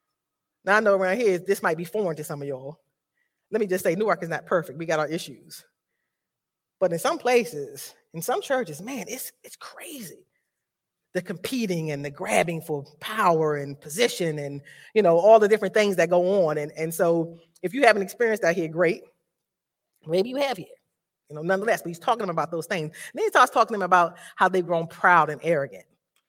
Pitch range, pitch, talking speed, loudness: 160-215 Hz, 175 Hz, 200 wpm, -24 LUFS